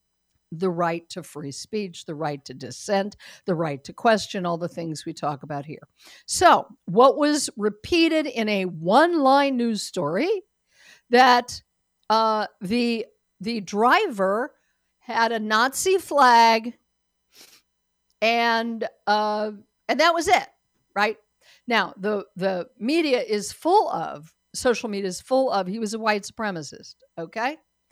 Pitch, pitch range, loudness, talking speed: 215 Hz, 175-250 Hz, -22 LUFS, 135 wpm